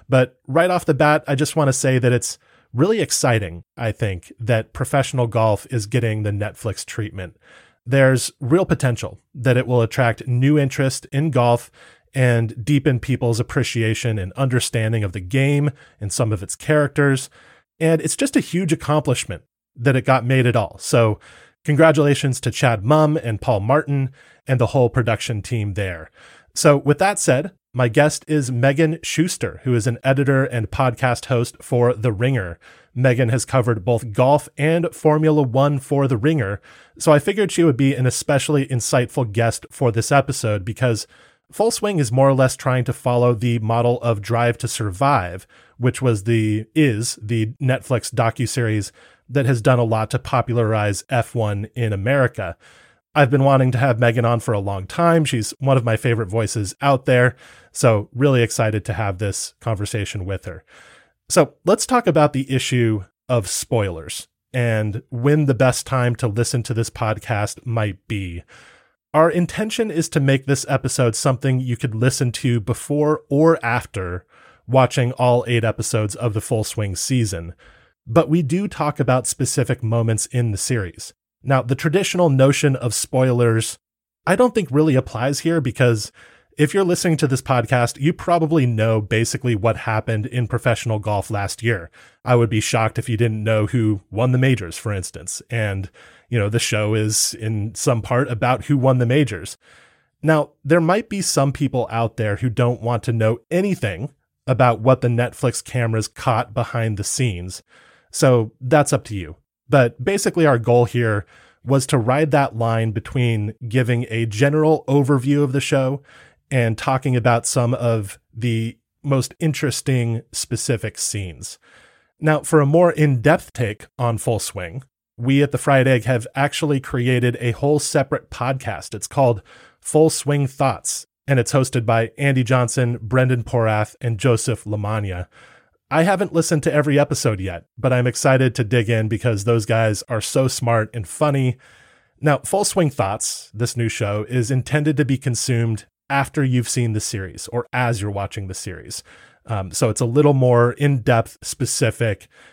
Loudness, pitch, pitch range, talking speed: -19 LUFS, 125 Hz, 115-140 Hz, 170 wpm